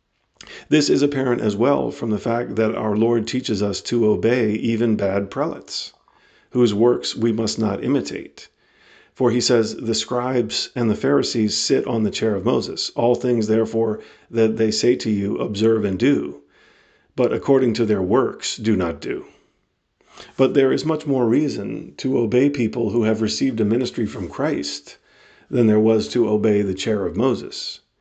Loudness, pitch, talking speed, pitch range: -20 LUFS, 115 Hz, 175 wpm, 105-125 Hz